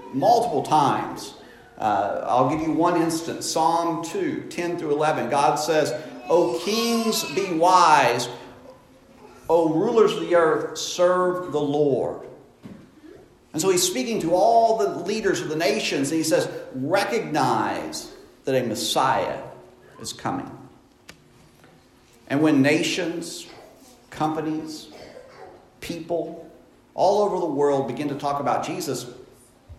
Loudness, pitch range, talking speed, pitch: -22 LUFS, 150-180 Hz, 125 wpm, 165 Hz